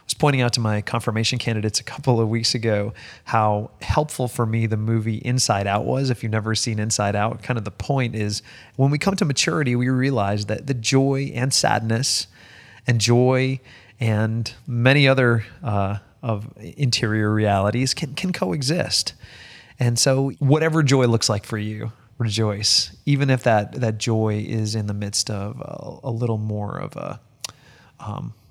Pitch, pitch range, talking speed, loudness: 115 Hz, 110-130 Hz, 175 wpm, -21 LUFS